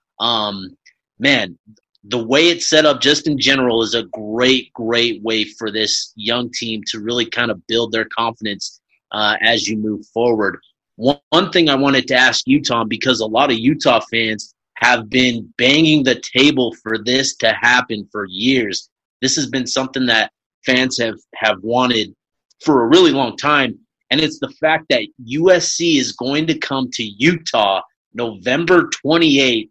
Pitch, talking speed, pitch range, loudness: 125 Hz, 170 wpm, 115-140 Hz, -16 LUFS